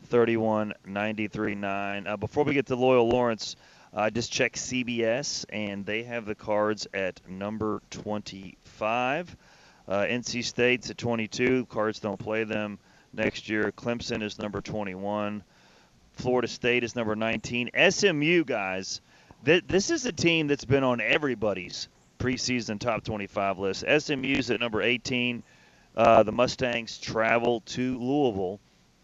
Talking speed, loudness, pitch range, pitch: 140 wpm, -27 LUFS, 105-125 Hz, 115 Hz